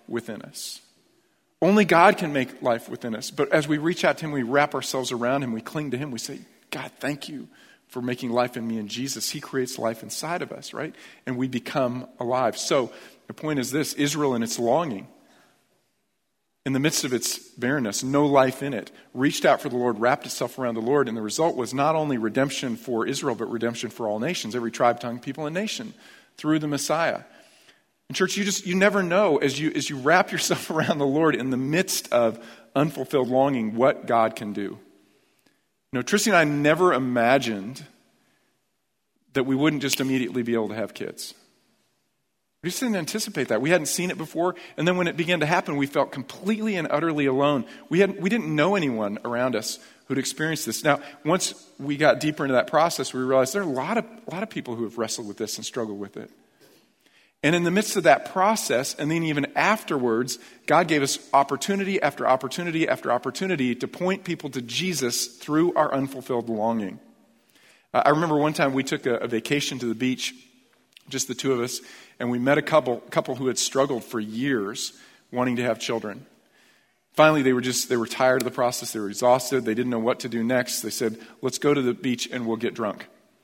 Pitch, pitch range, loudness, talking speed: 135 Hz, 120-155 Hz, -24 LUFS, 215 wpm